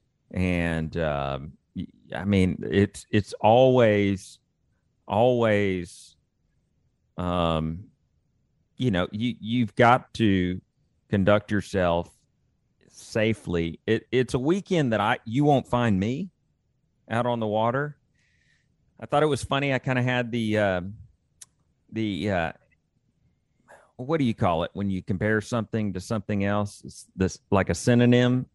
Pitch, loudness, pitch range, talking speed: 105 Hz, -25 LUFS, 95-125 Hz, 130 wpm